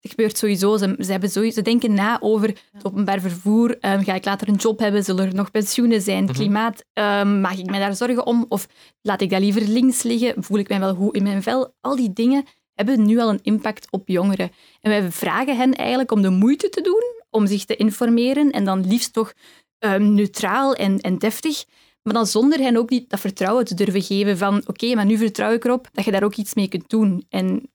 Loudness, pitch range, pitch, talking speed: -20 LUFS, 200-235 Hz, 215 Hz, 235 wpm